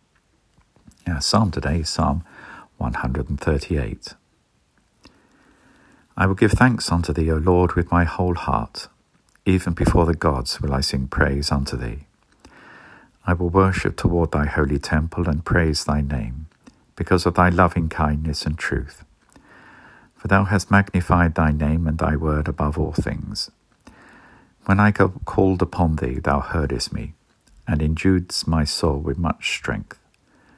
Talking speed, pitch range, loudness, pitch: 150 wpm, 75-90 Hz, -21 LUFS, 80 Hz